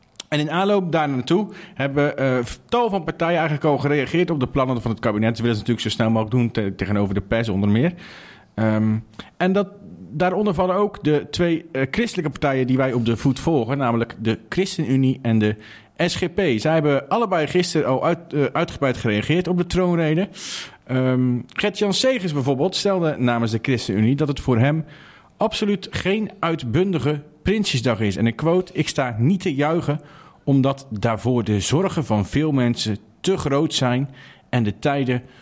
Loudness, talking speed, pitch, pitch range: -21 LUFS, 175 wpm, 145 Hz, 120-175 Hz